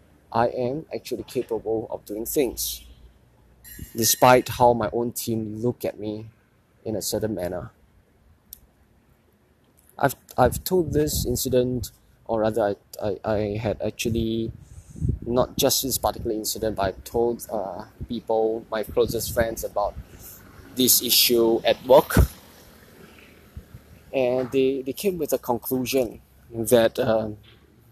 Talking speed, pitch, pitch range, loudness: 125 wpm, 115 Hz, 105-120 Hz, -23 LUFS